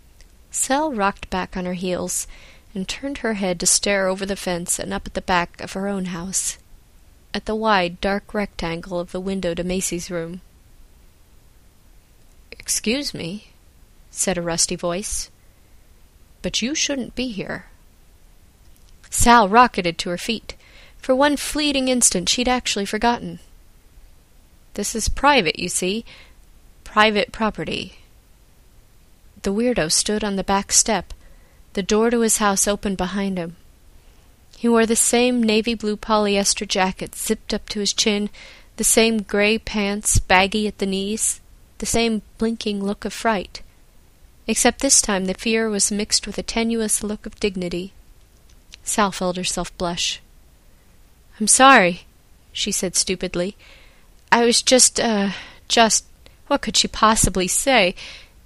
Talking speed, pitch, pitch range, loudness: 145 wpm, 200 Hz, 180-225 Hz, -20 LUFS